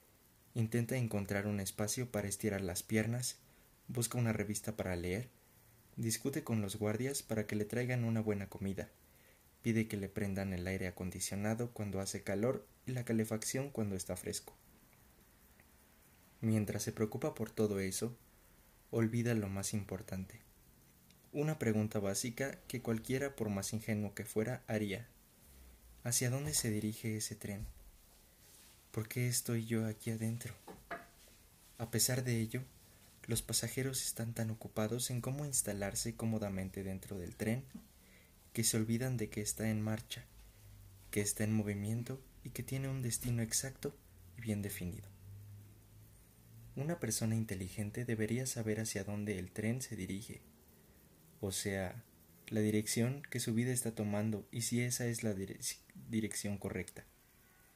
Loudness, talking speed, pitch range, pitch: -38 LUFS, 145 wpm, 100-115 Hz, 110 Hz